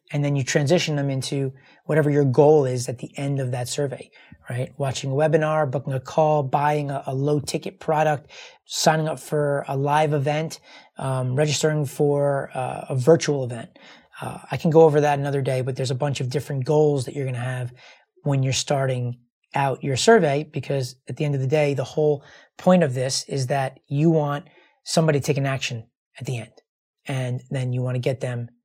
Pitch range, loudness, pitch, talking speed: 130-150 Hz, -22 LUFS, 140 Hz, 205 wpm